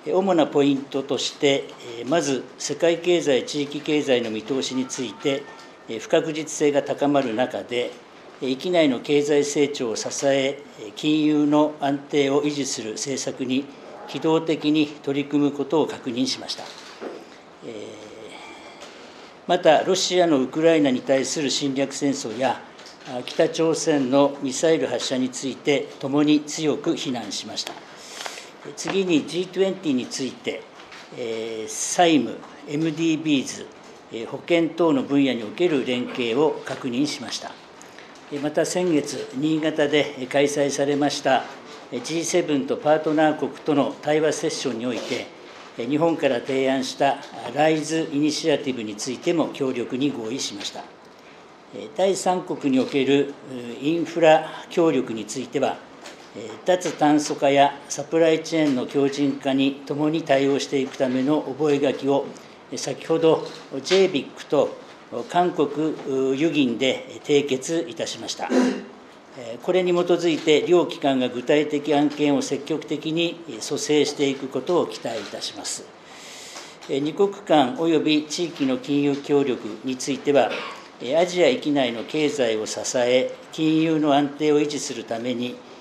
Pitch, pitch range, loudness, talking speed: 145 Hz, 135-160 Hz, -23 LUFS, 260 characters per minute